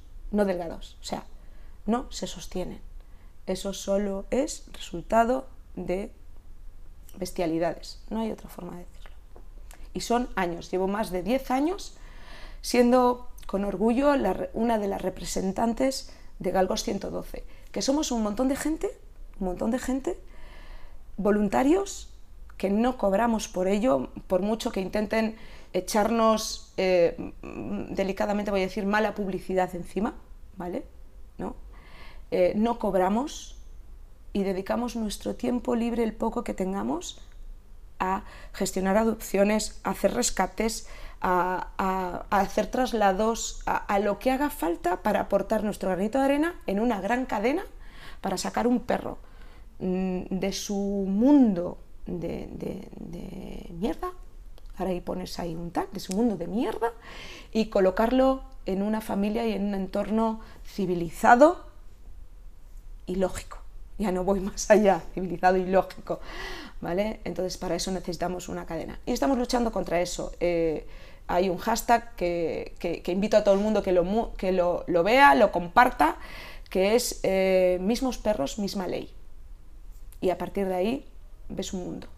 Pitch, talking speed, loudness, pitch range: 200 Hz, 140 wpm, -27 LUFS, 180-230 Hz